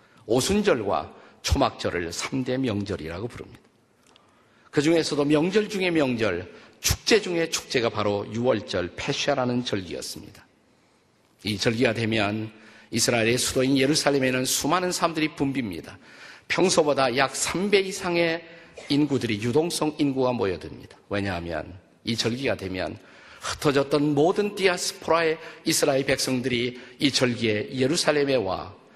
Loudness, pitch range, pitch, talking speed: -24 LUFS, 120-160 Hz, 135 Hz, 305 characters per minute